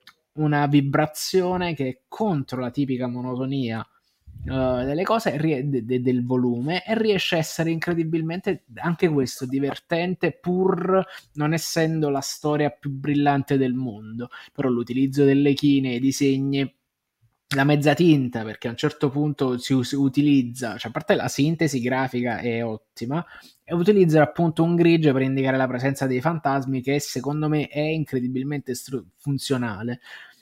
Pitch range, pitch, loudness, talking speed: 130-160 Hz, 140 Hz, -23 LUFS, 145 wpm